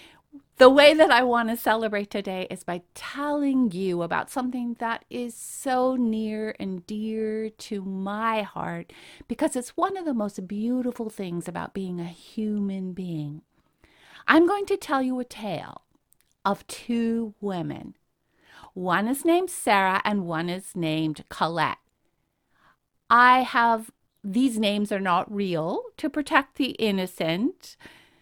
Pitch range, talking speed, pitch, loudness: 190-255 Hz, 140 wpm, 220 Hz, -25 LUFS